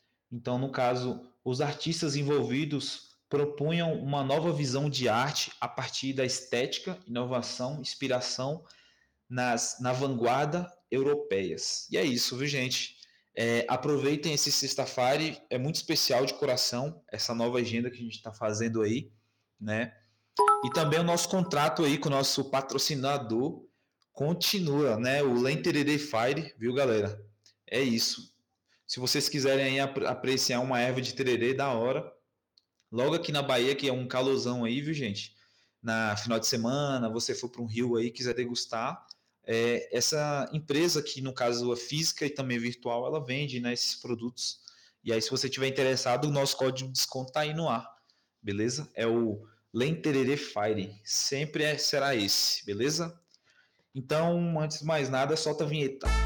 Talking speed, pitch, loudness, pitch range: 160 wpm, 130 Hz, -29 LUFS, 120-145 Hz